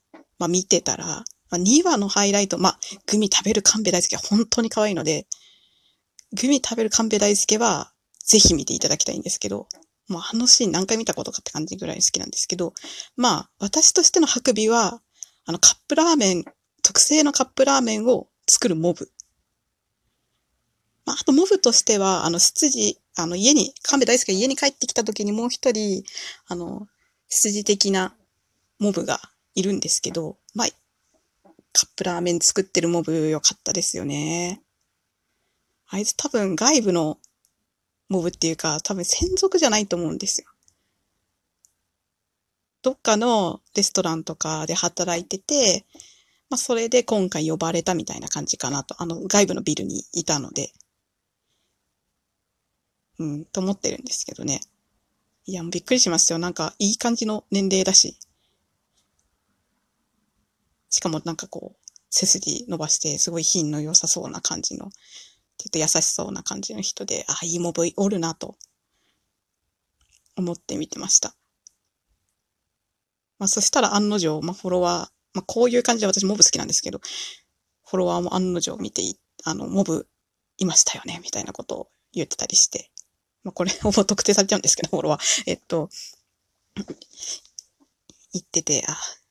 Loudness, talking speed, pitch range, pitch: -20 LUFS, 315 characters per minute, 170-230 Hz, 195 Hz